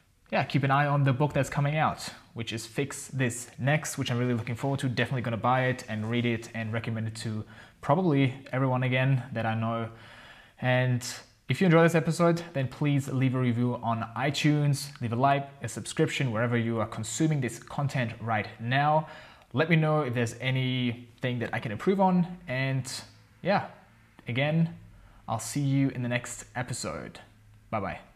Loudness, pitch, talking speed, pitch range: -28 LUFS, 125 Hz, 185 wpm, 115-140 Hz